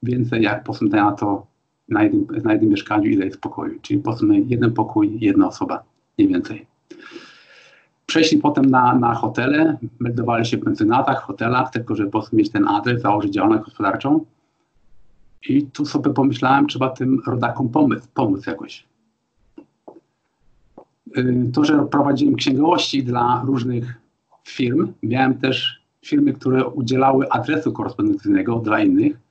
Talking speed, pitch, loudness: 145 wpm, 150 Hz, -19 LUFS